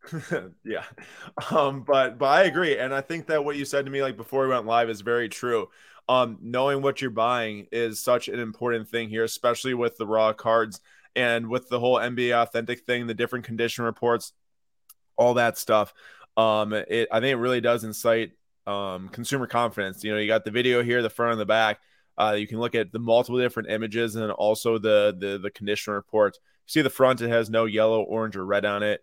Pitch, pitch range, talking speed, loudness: 115 Hz, 110-125 Hz, 215 wpm, -25 LUFS